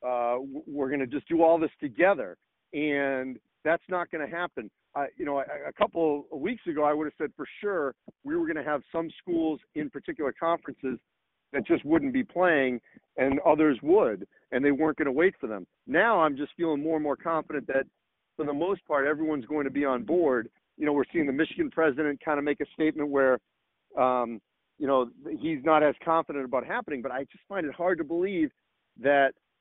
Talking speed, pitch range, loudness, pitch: 215 wpm, 140-170 Hz, -28 LUFS, 150 Hz